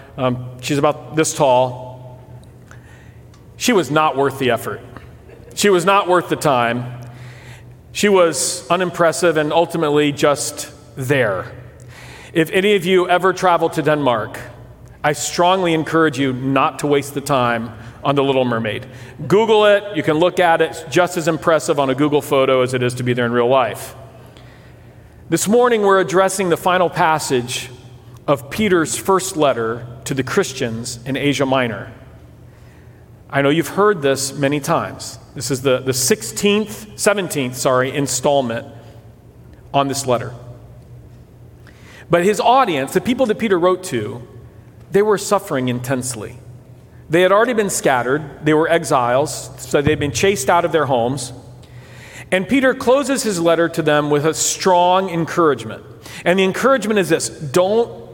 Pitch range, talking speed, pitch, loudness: 125-175 Hz, 155 wpm, 145 Hz, -17 LUFS